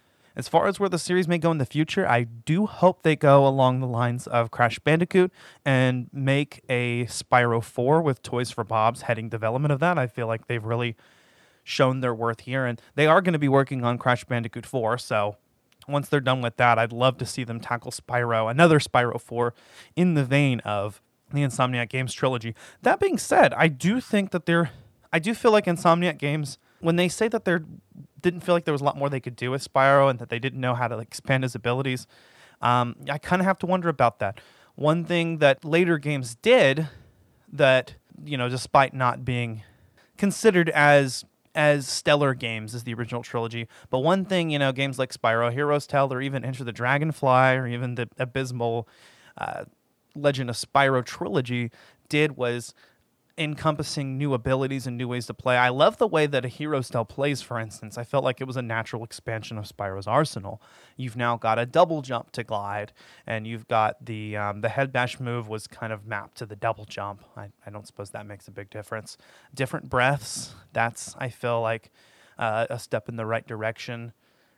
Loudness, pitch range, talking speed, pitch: -24 LUFS, 115-145 Hz, 205 wpm, 125 Hz